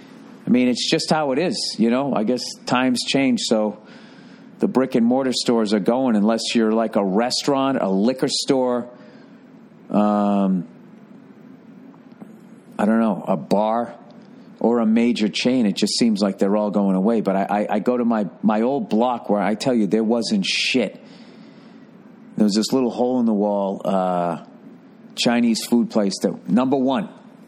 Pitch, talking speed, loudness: 120 Hz, 175 wpm, -20 LUFS